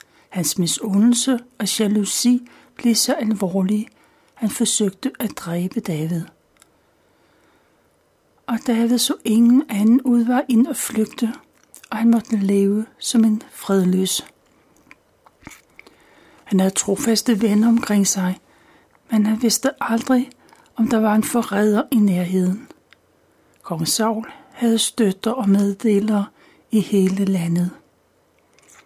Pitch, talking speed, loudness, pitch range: 220 Hz, 115 wpm, -19 LUFS, 200-235 Hz